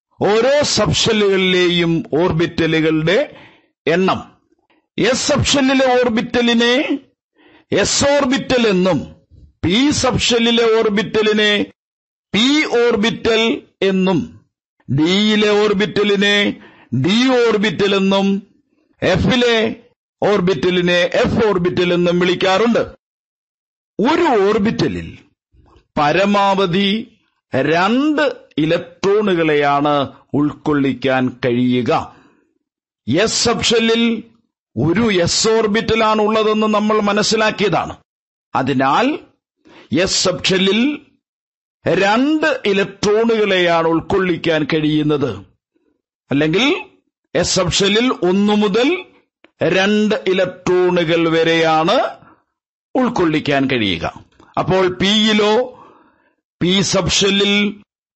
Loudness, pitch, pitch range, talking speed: -15 LUFS, 205 Hz, 175-235 Hz, 65 wpm